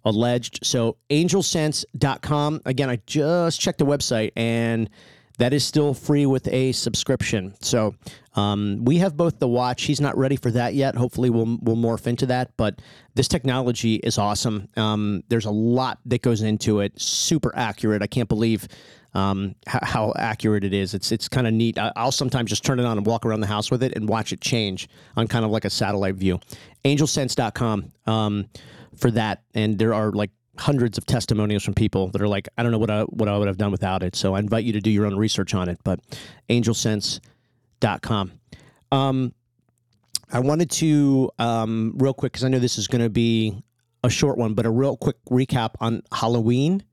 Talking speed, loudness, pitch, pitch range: 195 wpm, -22 LUFS, 115 Hz, 110-130 Hz